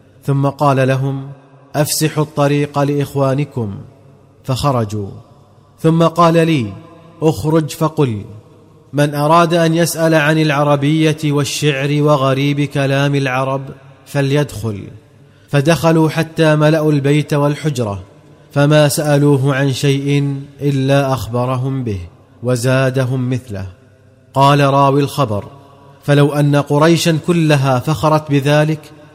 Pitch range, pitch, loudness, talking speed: 135-150 Hz, 140 Hz, -14 LUFS, 95 wpm